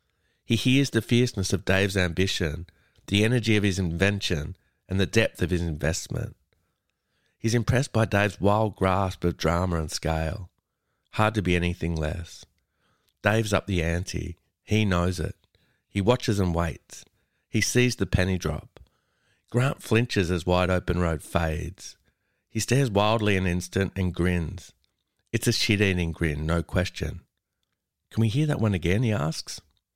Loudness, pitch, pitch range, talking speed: -25 LUFS, 95 Hz, 85-110 Hz, 155 wpm